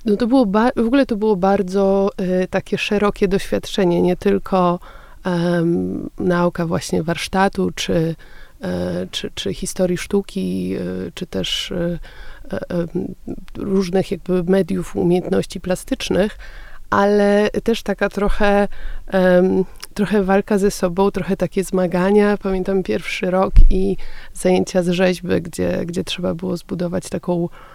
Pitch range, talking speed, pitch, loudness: 180-200 Hz, 130 wpm, 190 Hz, -19 LUFS